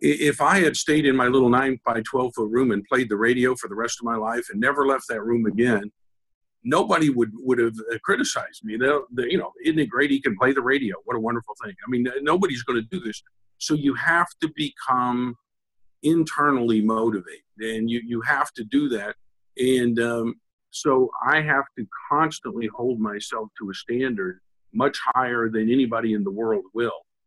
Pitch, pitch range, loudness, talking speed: 120 Hz, 110-130 Hz, -23 LUFS, 200 wpm